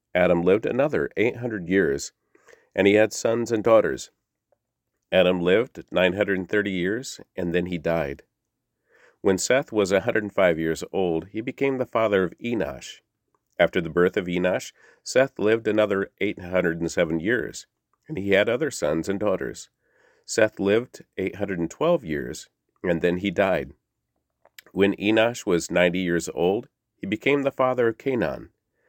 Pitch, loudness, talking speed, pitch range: 95 Hz, -24 LUFS, 170 wpm, 90-110 Hz